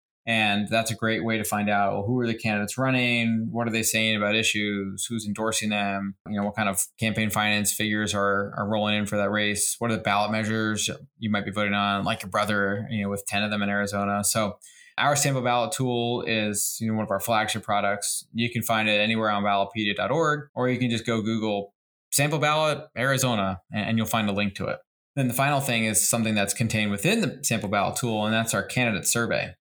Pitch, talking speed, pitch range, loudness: 110 Hz, 230 wpm, 100-115 Hz, -25 LUFS